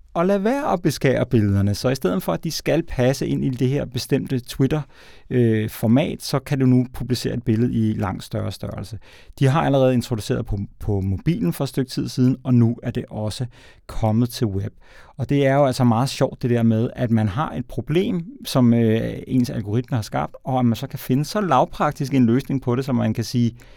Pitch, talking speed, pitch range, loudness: 125 Hz, 225 wpm, 115-140 Hz, -21 LUFS